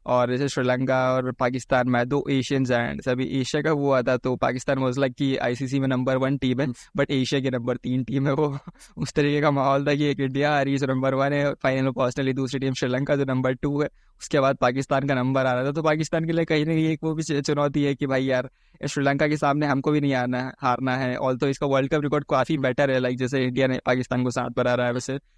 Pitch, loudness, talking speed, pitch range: 135 Hz, -24 LUFS, 265 wpm, 130-145 Hz